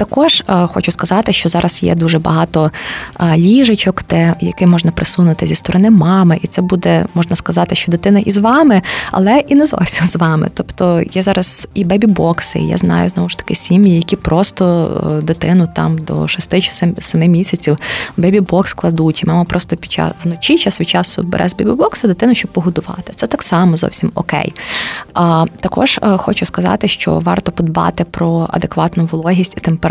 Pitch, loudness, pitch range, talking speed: 175 Hz, -12 LUFS, 165-190 Hz, 175 wpm